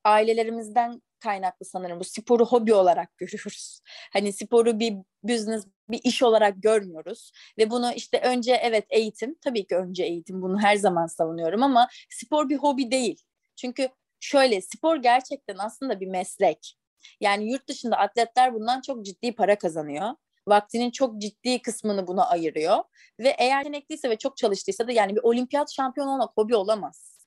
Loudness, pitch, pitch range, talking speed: -24 LUFS, 225 Hz, 200-250 Hz, 155 wpm